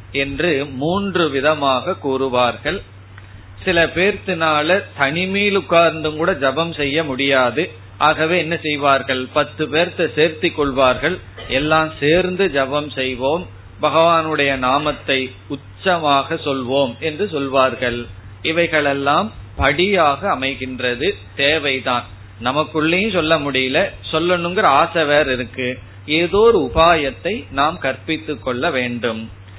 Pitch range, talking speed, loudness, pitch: 125-165 Hz, 95 wpm, -17 LUFS, 145 Hz